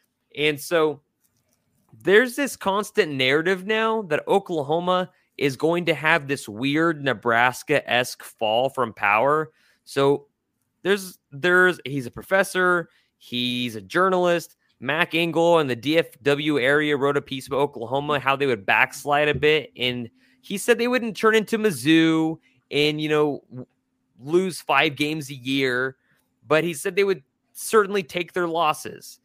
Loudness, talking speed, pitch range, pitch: -22 LUFS, 145 wpm, 135-180 Hz, 155 Hz